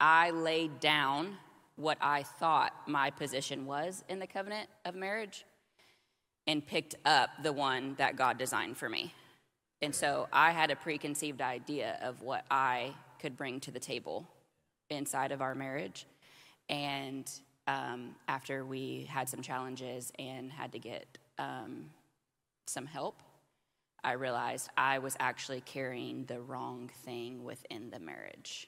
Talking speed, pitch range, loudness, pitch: 145 wpm, 130-155 Hz, -35 LUFS, 135 Hz